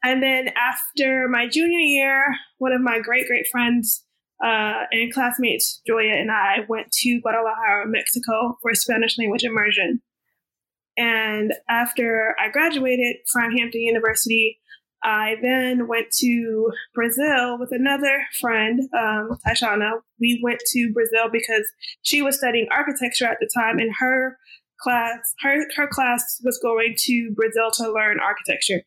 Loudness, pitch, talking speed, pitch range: -20 LUFS, 240 Hz, 140 wpm, 225-255 Hz